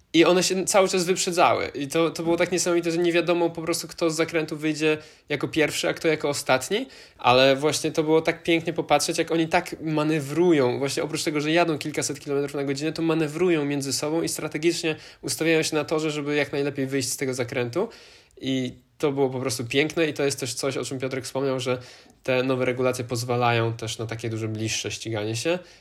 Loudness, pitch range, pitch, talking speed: -24 LUFS, 130-165 Hz, 150 Hz, 210 wpm